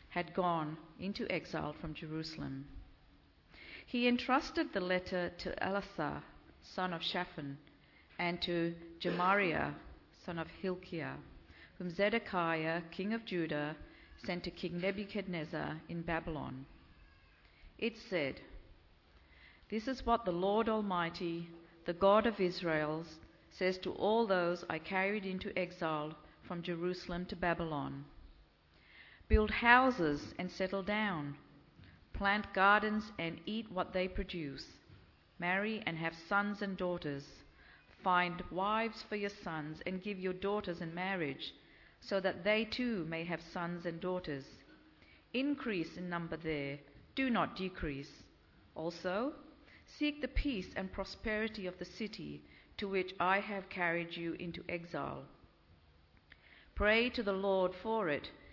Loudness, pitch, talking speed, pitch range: -37 LUFS, 180 Hz, 125 wpm, 160-200 Hz